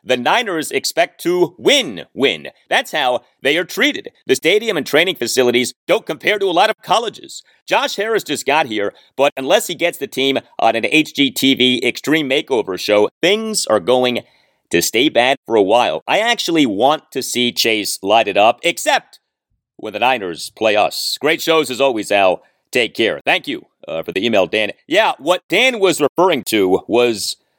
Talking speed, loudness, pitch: 185 wpm, -16 LUFS, 150 Hz